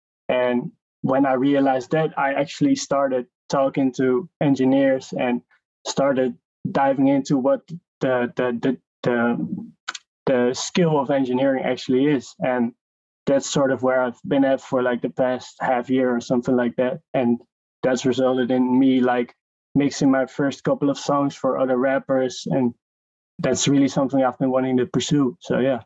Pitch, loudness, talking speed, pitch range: 130 Hz, -21 LUFS, 160 wpm, 125-140 Hz